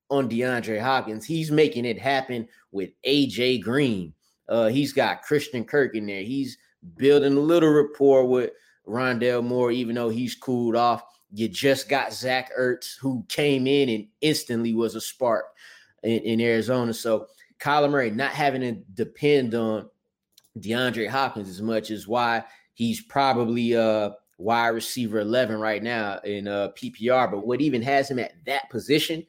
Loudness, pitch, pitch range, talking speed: -24 LUFS, 125 Hz, 115-140 Hz, 165 wpm